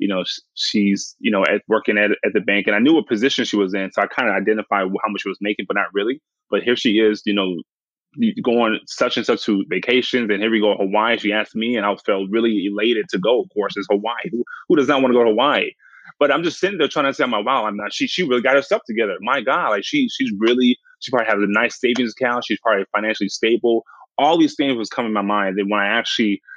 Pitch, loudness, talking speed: 115 Hz, -19 LUFS, 275 wpm